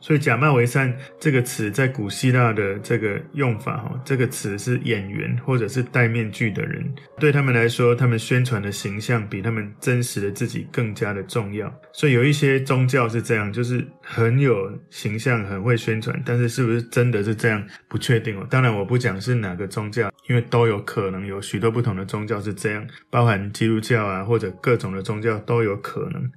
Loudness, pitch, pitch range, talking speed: -22 LUFS, 120 Hz, 110-130 Hz, 310 characters per minute